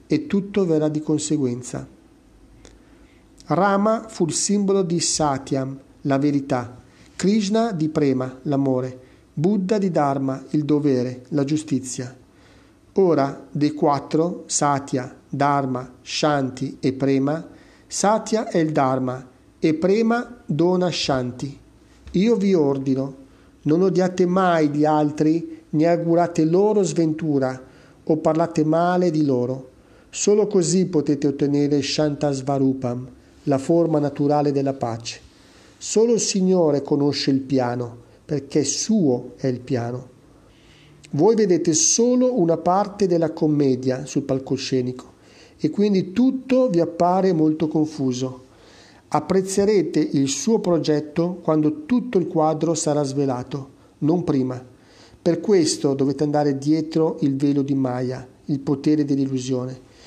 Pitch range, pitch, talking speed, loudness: 135-170 Hz, 150 Hz, 120 wpm, -21 LUFS